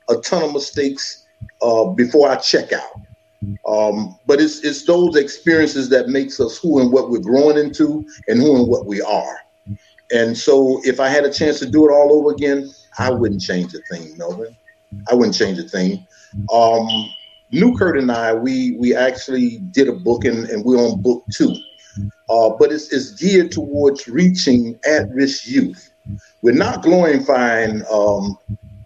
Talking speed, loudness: 175 wpm, -16 LUFS